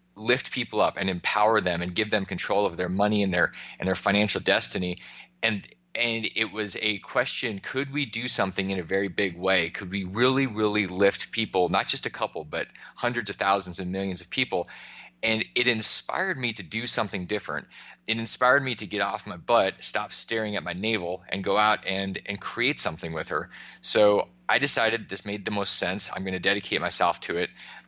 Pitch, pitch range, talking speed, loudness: 100 Hz, 95-110 Hz, 210 wpm, -25 LUFS